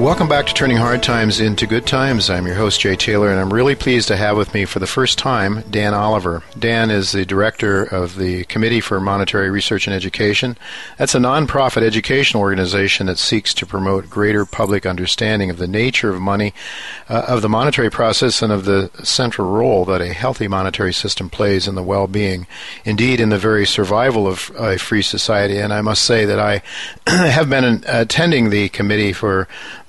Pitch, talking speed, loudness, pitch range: 105 Hz, 195 wpm, -16 LUFS, 95-115 Hz